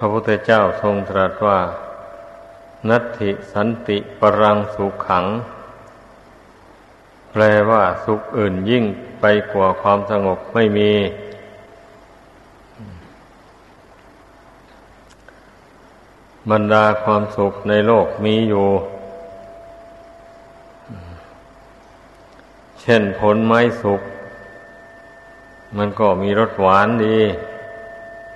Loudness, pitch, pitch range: -17 LUFS, 105 Hz, 100-110 Hz